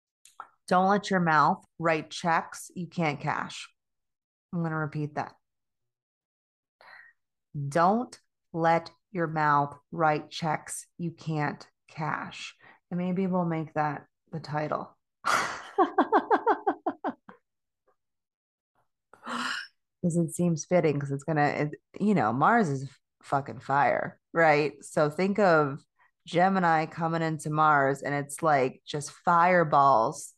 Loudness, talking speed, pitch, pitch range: -27 LUFS, 115 wpm, 160 Hz, 145-175 Hz